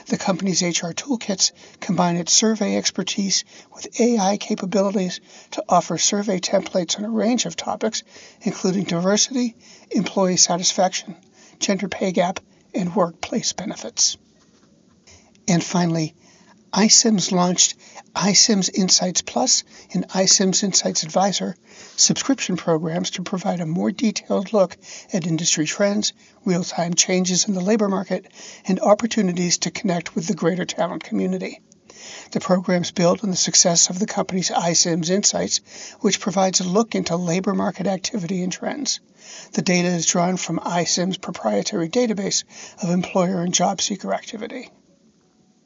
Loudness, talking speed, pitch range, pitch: -20 LUFS, 135 wpm, 175-210 Hz, 190 Hz